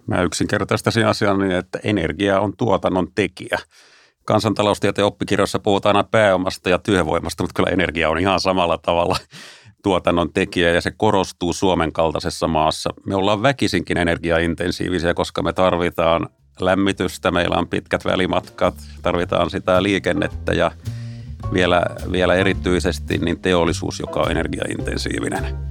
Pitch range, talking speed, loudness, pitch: 85-100 Hz, 130 wpm, -19 LUFS, 90 Hz